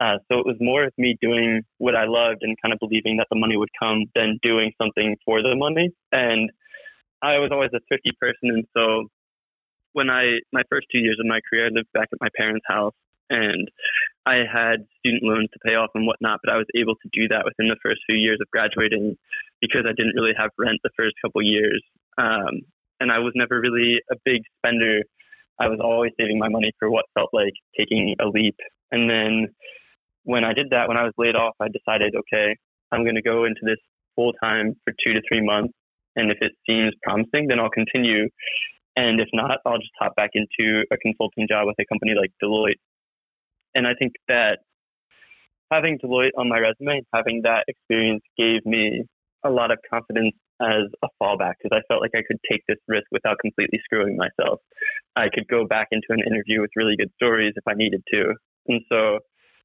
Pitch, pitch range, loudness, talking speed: 115 Hz, 110-120 Hz, -21 LUFS, 210 wpm